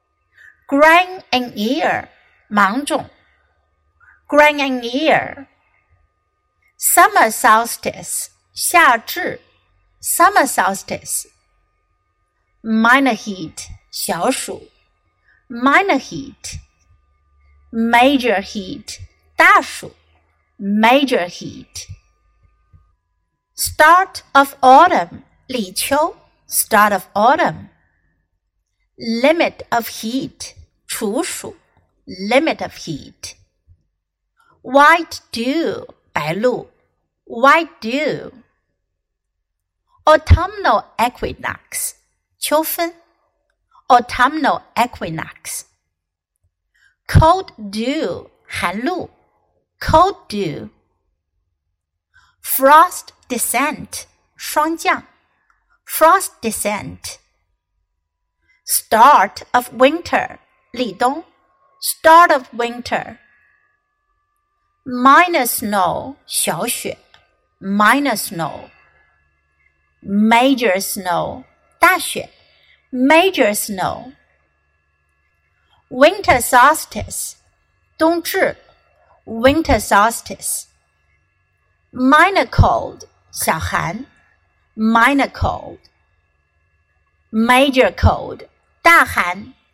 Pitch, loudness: 220 Hz, -15 LUFS